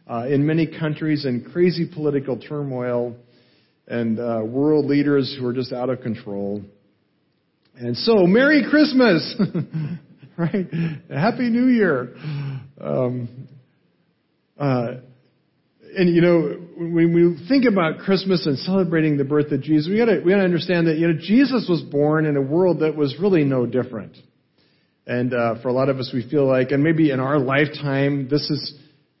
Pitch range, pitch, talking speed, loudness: 130-170 Hz, 150 Hz, 160 wpm, -20 LUFS